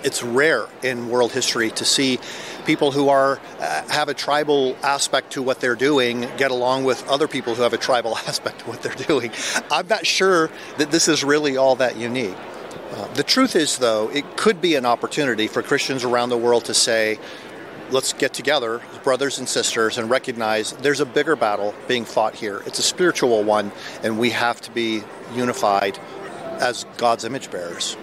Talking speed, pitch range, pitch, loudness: 190 wpm, 115-145 Hz, 125 Hz, -20 LUFS